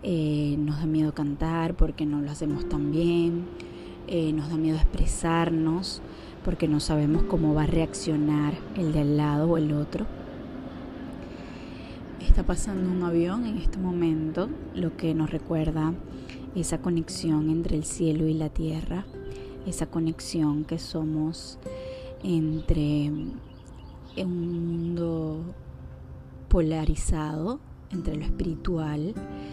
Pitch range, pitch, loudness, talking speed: 150-170 Hz, 160 Hz, -28 LUFS, 120 wpm